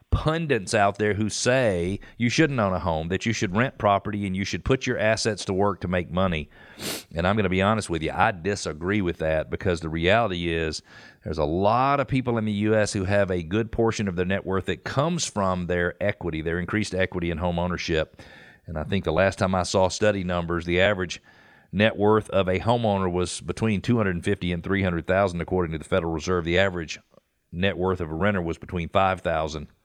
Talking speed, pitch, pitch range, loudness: 215 wpm, 95 Hz, 90-105 Hz, -24 LUFS